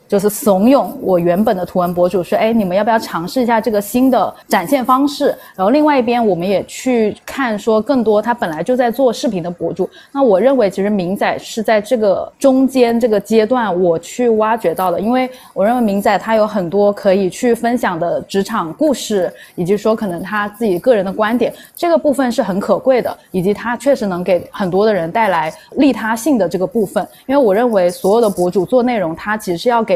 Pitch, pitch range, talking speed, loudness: 220 Hz, 190-250 Hz, 325 characters per minute, -15 LUFS